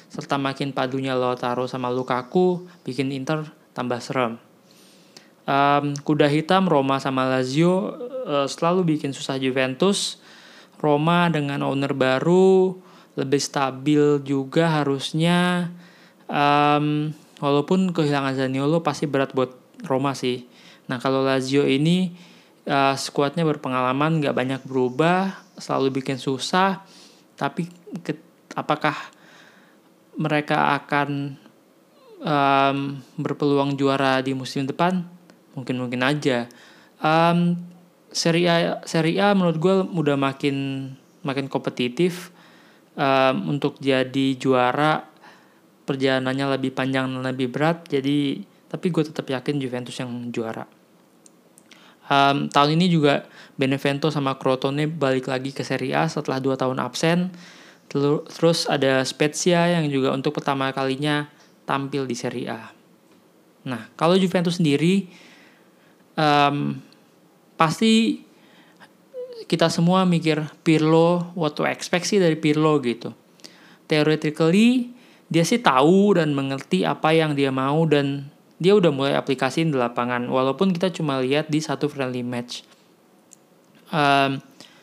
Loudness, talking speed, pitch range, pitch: -22 LUFS, 120 wpm, 135-170 Hz, 145 Hz